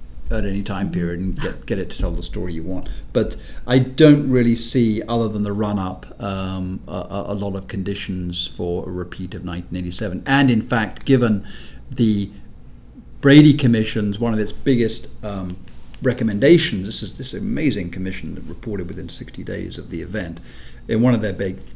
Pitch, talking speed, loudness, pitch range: 100 Hz, 185 wpm, -20 LUFS, 90-115 Hz